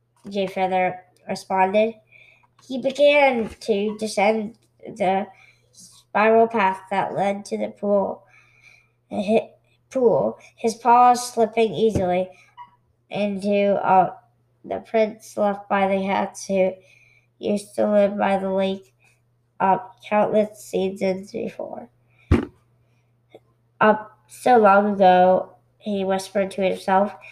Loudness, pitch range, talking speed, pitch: -21 LUFS, 180-210 Hz, 105 wpm, 195 Hz